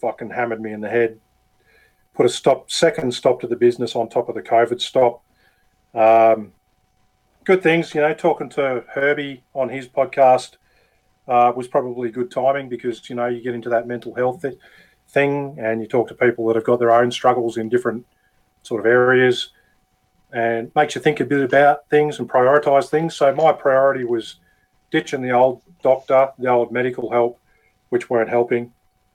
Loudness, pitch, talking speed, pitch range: -19 LUFS, 125 Hz, 185 wpm, 120-140 Hz